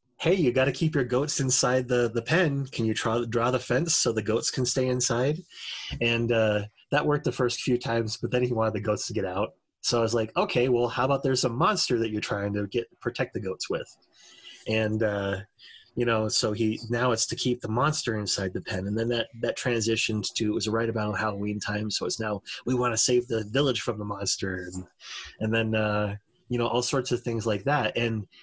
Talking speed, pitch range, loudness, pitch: 235 wpm, 110-125 Hz, -27 LUFS, 115 Hz